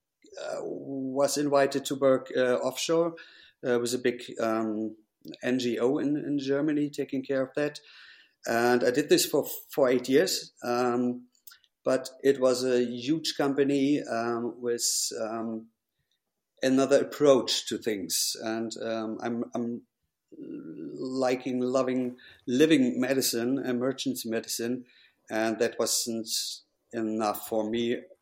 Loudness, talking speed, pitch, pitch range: -28 LUFS, 125 wpm, 125 Hz, 115-140 Hz